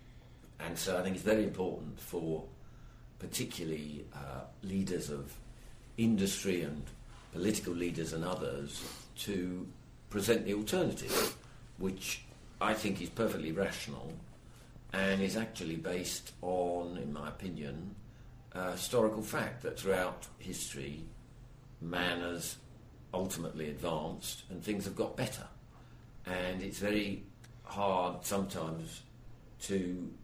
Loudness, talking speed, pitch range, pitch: -37 LUFS, 115 wpm, 85-110 Hz, 95 Hz